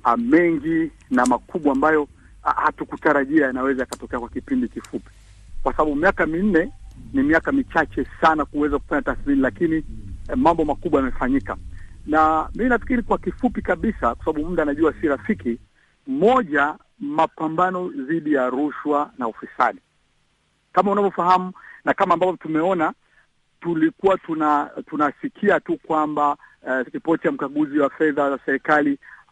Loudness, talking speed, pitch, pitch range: -21 LUFS, 120 wpm, 155 Hz, 135-190 Hz